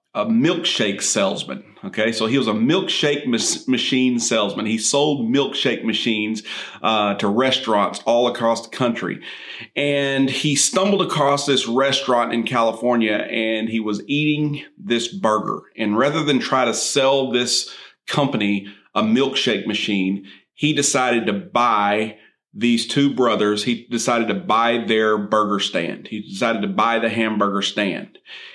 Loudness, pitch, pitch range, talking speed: -19 LUFS, 115 Hz, 110-135 Hz, 145 wpm